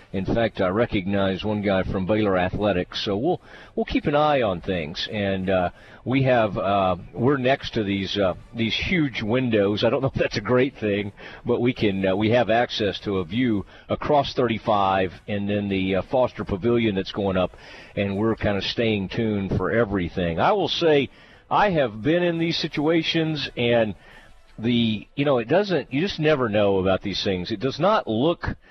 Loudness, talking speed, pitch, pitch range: -23 LUFS, 195 wpm, 110 Hz, 95-125 Hz